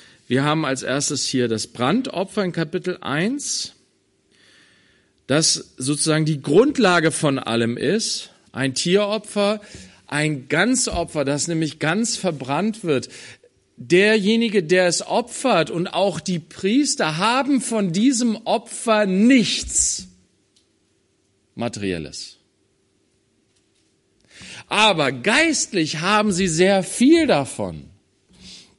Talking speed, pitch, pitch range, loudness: 100 wpm, 170 Hz, 135-215 Hz, -20 LUFS